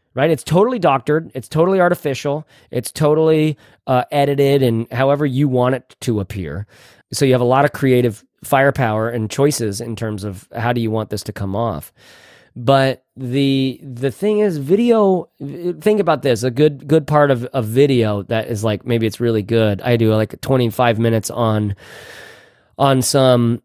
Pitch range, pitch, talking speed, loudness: 115-145 Hz, 130 Hz, 180 wpm, -17 LUFS